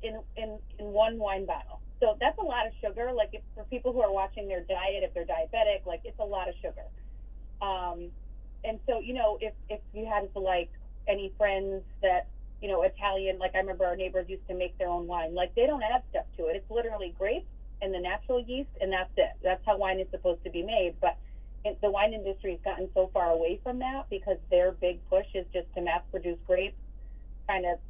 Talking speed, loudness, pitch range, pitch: 230 wpm, -31 LUFS, 180-215 Hz, 195 Hz